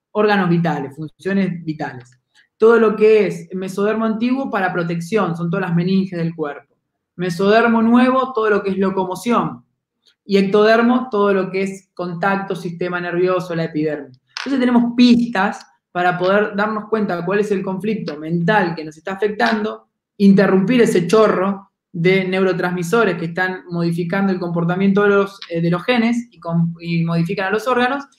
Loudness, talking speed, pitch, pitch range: -17 LUFS, 160 wpm, 195 Hz, 175-215 Hz